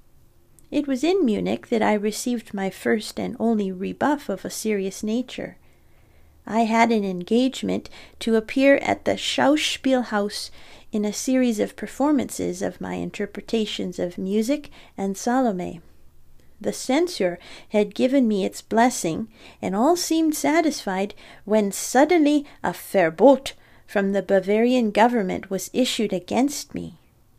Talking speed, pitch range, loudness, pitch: 130 wpm, 200-265 Hz, -23 LUFS, 225 Hz